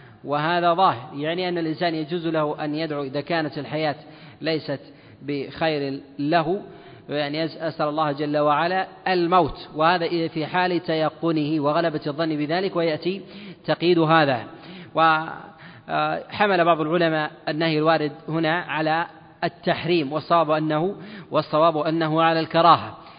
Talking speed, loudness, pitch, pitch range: 115 wpm, -22 LUFS, 160 Hz, 150-170 Hz